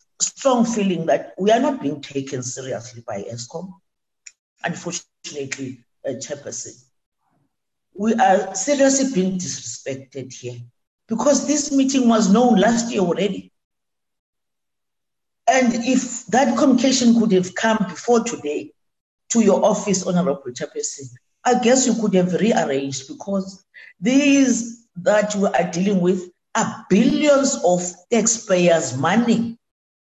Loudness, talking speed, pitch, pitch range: -19 LUFS, 120 wpm, 200 Hz, 165-235 Hz